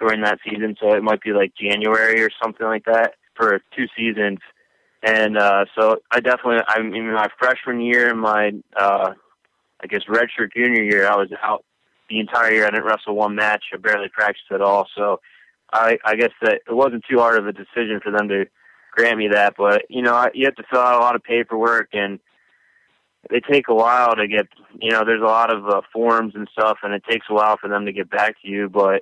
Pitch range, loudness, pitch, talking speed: 105-115 Hz, -18 LUFS, 110 Hz, 230 wpm